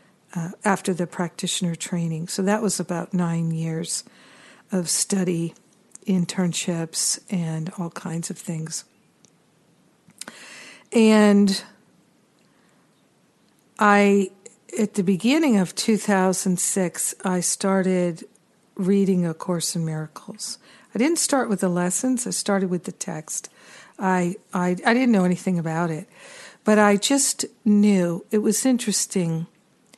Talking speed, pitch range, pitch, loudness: 120 wpm, 175-210 Hz, 190 Hz, -22 LUFS